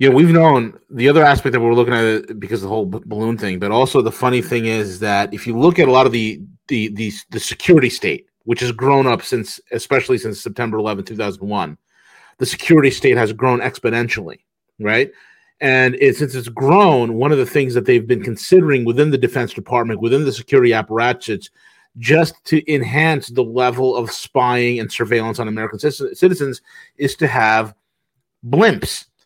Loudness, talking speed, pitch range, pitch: -16 LUFS, 190 wpm, 115-140 Hz, 125 Hz